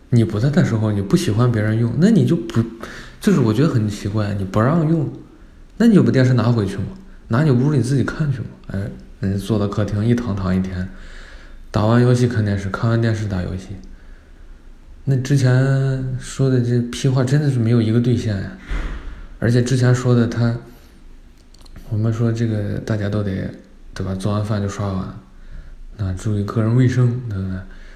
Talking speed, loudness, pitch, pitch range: 270 characters per minute, -19 LUFS, 110 Hz, 95-125 Hz